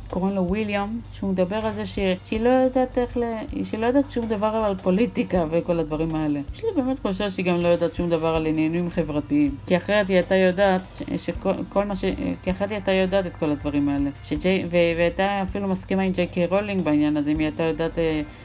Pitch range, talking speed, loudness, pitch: 165-205 Hz, 190 wpm, -23 LUFS, 185 Hz